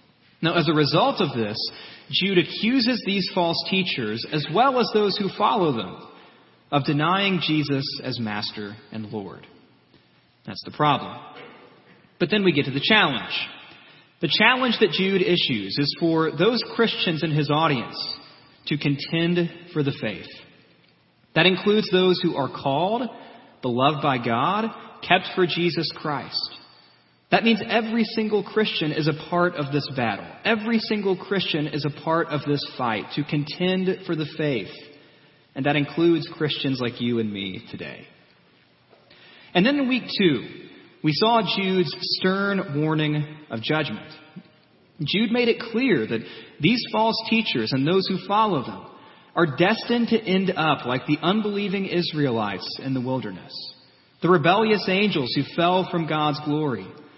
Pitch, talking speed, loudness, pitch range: 165 Hz, 150 wpm, -23 LUFS, 145-190 Hz